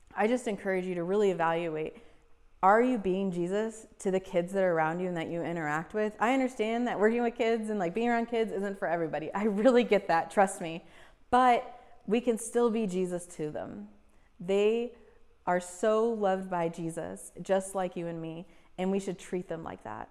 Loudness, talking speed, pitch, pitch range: -30 LUFS, 205 wpm, 195 Hz, 175-225 Hz